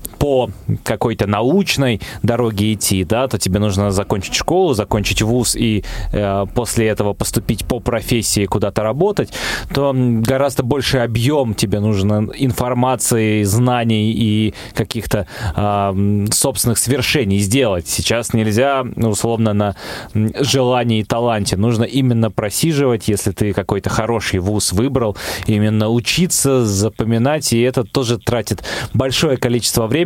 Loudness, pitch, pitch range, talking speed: -16 LUFS, 115 Hz, 105-125 Hz, 125 wpm